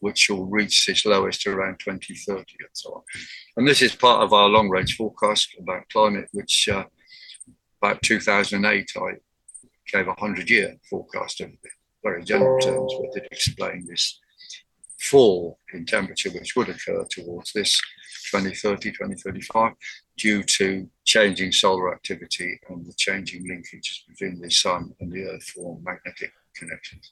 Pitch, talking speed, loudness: 130 Hz, 140 wpm, -21 LUFS